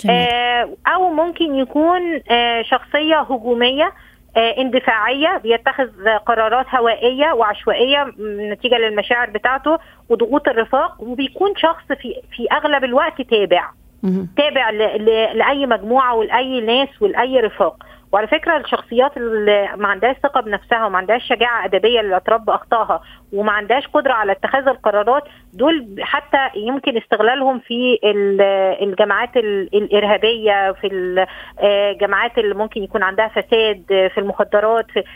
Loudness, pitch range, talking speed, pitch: -16 LUFS, 210-270 Hz, 110 wpm, 235 Hz